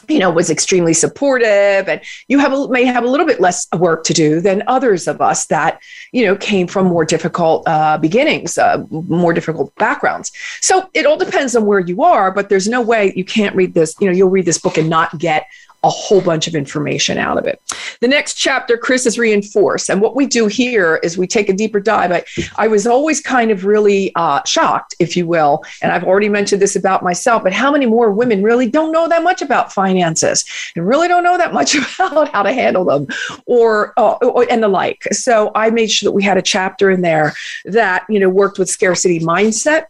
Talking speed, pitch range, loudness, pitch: 225 wpm, 180-250 Hz, -14 LUFS, 205 Hz